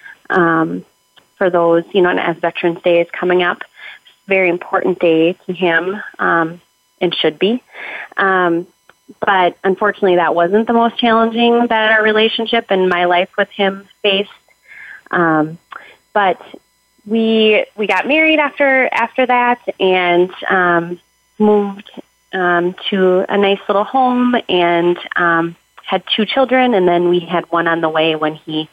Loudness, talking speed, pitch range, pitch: -14 LUFS, 150 wpm, 175-225 Hz, 190 Hz